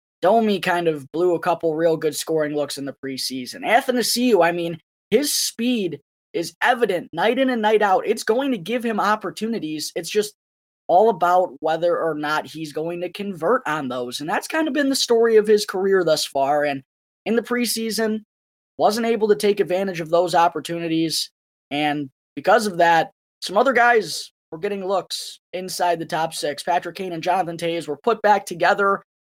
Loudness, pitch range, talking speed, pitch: -21 LUFS, 160-215 Hz, 185 wpm, 180 Hz